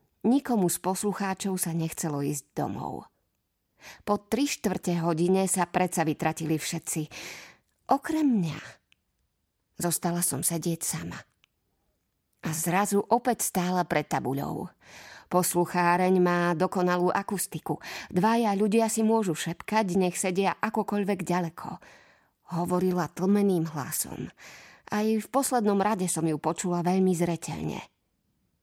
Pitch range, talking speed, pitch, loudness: 165-205 Hz, 110 wpm, 180 Hz, -27 LUFS